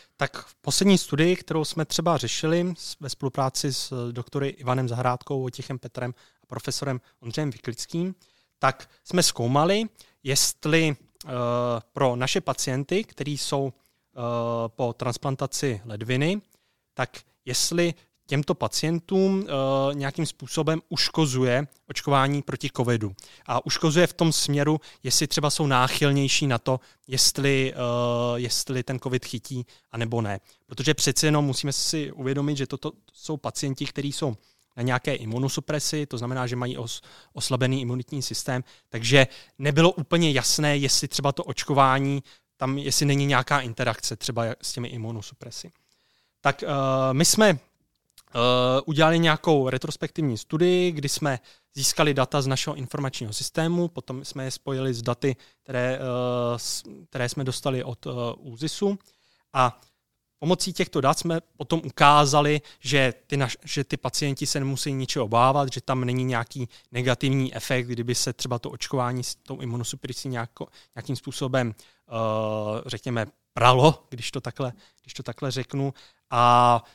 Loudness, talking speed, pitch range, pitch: -25 LUFS, 140 wpm, 125-150 Hz, 135 Hz